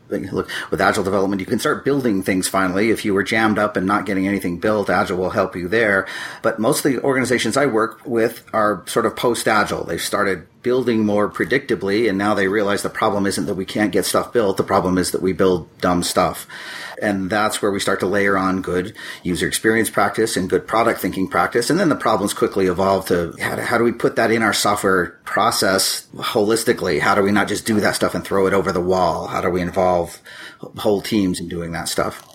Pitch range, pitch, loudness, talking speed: 95-105 Hz, 95 Hz, -19 LUFS, 225 wpm